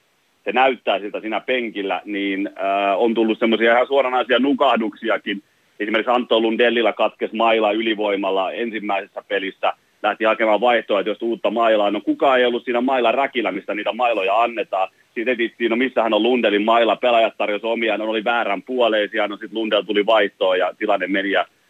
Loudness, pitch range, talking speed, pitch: -19 LUFS, 105-120 Hz, 170 wpm, 110 Hz